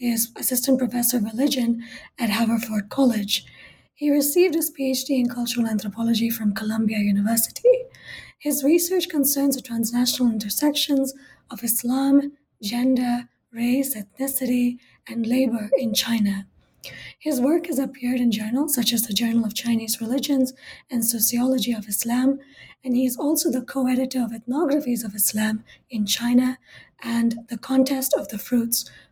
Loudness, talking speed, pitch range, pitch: -22 LUFS, 140 wpm, 230-270 Hz, 245 Hz